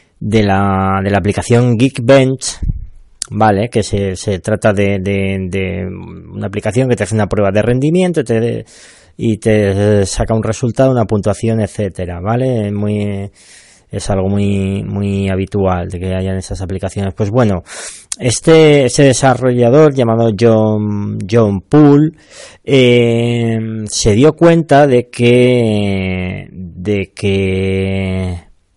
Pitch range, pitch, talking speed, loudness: 100-120 Hz, 105 Hz, 130 wpm, -13 LUFS